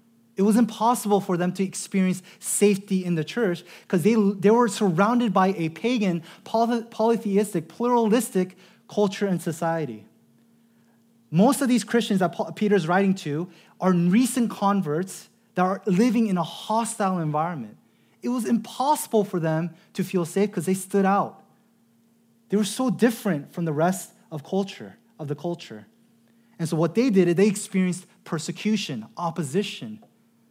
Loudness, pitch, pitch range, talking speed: -24 LUFS, 200 Hz, 180-230 Hz, 150 wpm